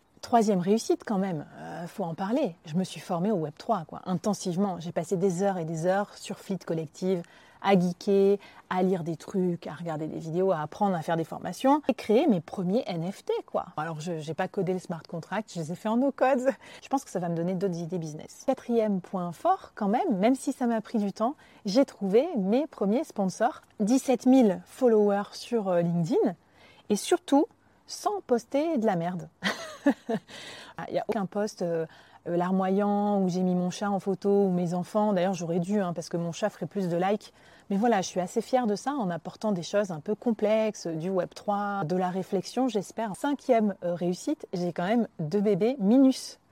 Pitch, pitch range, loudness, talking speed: 195 Hz, 180-225 Hz, -28 LUFS, 205 wpm